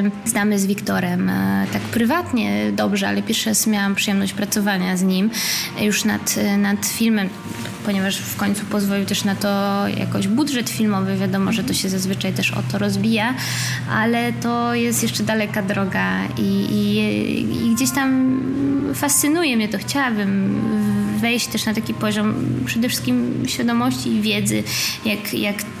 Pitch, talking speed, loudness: 200 Hz, 150 wpm, -20 LUFS